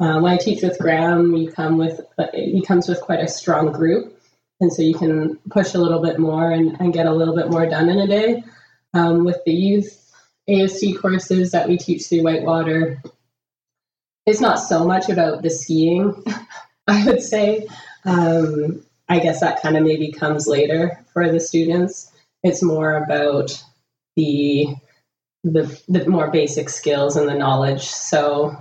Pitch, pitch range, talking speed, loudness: 165 Hz, 155-180 Hz, 170 wpm, -18 LUFS